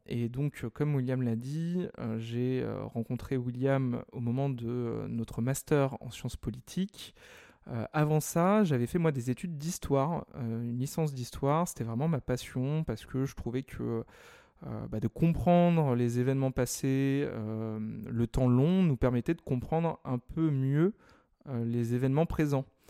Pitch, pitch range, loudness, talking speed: 130 Hz, 120-155 Hz, -31 LUFS, 145 wpm